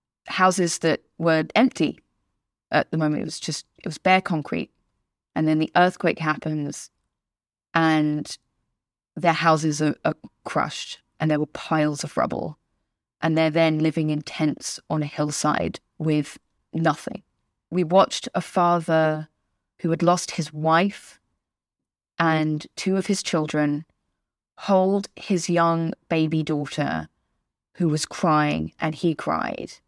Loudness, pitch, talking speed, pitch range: -23 LUFS, 160 Hz, 135 wpm, 150-170 Hz